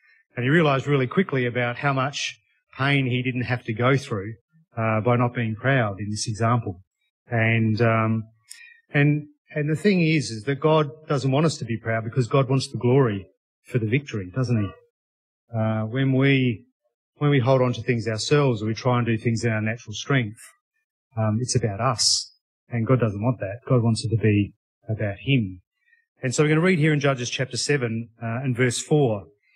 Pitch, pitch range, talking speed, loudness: 125 Hz, 115-140 Hz, 205 wpm, -23 LUFS